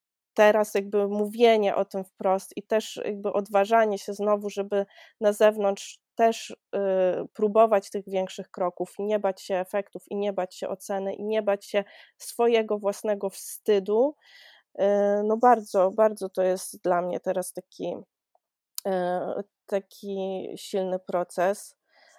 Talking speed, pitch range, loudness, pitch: 140 wpm, 190-215 Hz, -26 LUFS, 200 Hz